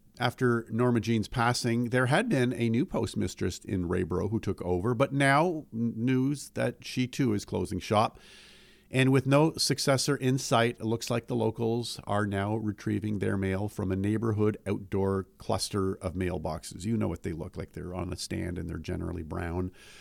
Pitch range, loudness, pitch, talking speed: 95-125 Hz, -29 LUFS, 110 Hz, 185 wpm